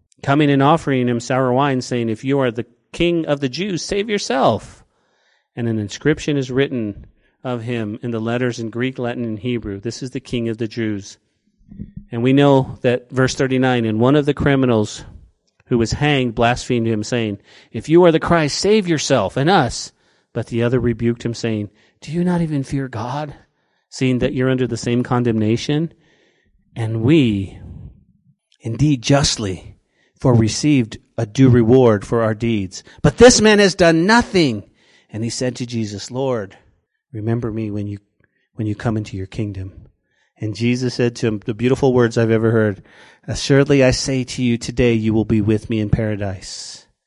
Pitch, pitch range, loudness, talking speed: 120 Hz, 110-135 Hz, -18 LUFS, 180 wpm